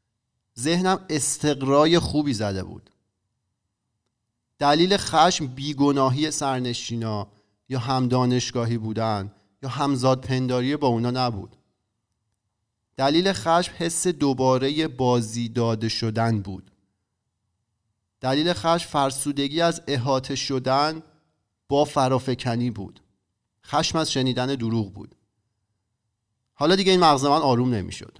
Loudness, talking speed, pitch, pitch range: -23 LUFS, 105 wpm, 125 Hz, 110-145 Hz